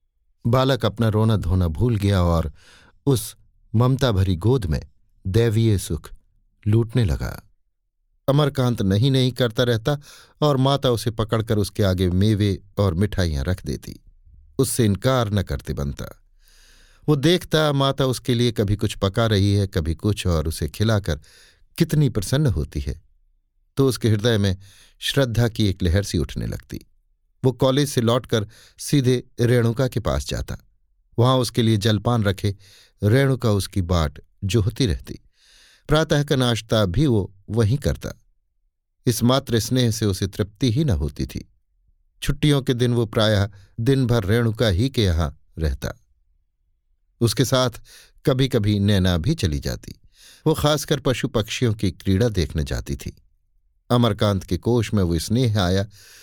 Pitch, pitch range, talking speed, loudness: 105 Hz, 90-125 Hz, 150 wpm, -21 LUFS